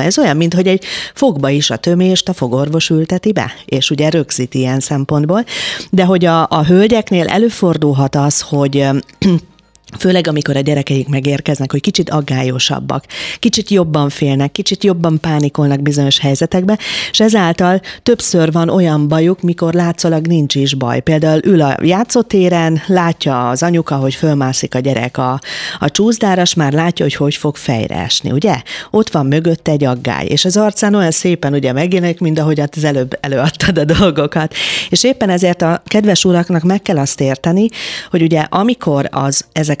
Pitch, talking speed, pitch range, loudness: 160 Hz, 165 wpm, 145-185 Hz, -13 LUFS